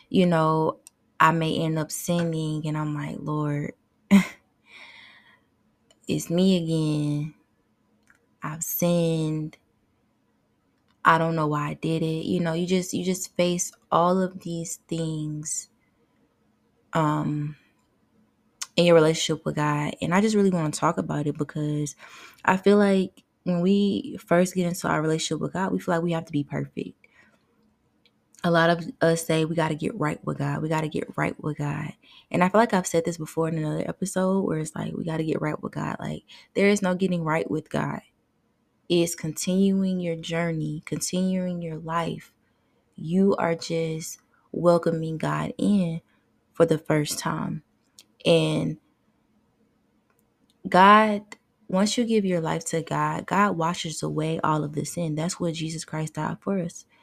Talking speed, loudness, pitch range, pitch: 165 wpm, -25 LUFS, 155-180 Hz, 165 Hz